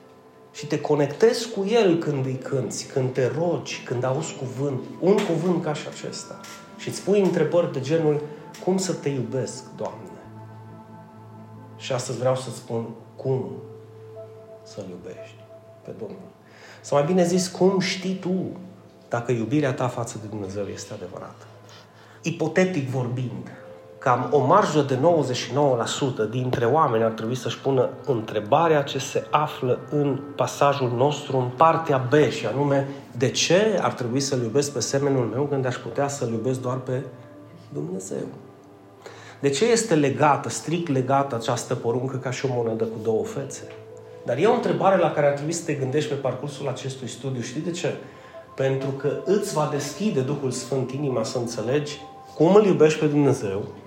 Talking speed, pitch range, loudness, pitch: 160 wpm, 120-150 Hz, -24 LUFS, 135 Hz